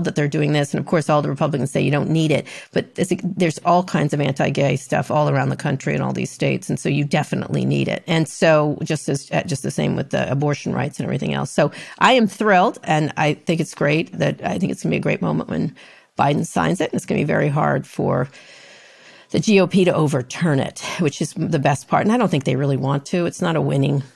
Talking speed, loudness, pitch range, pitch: 260 wpm, -20 LUFS, 145-175 Hz, 155 Hz